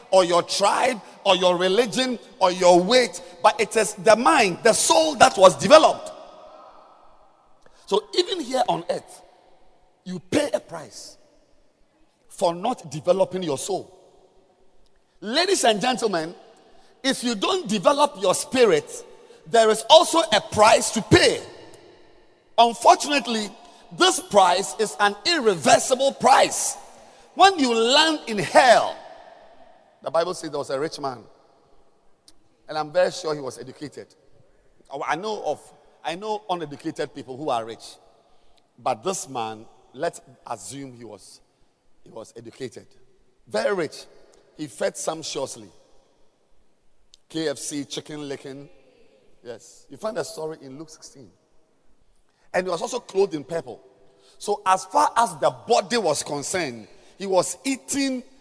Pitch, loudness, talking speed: 205 Hz, -21 LUFS, 135 wpm